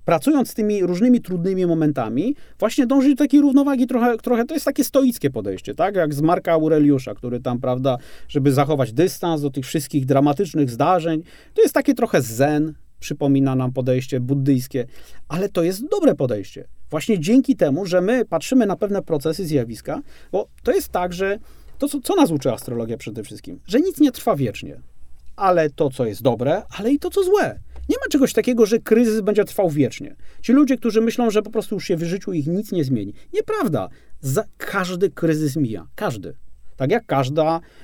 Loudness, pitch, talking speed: -20 LUFS, 180 Hz, 190 wpm